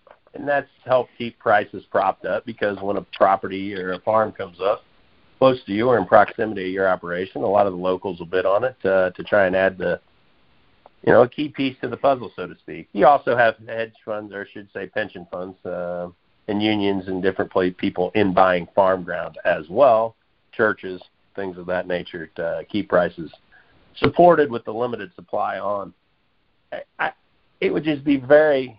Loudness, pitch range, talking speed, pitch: -21 LUFS, 95-115 Hz, 200 wpm, 100 Hz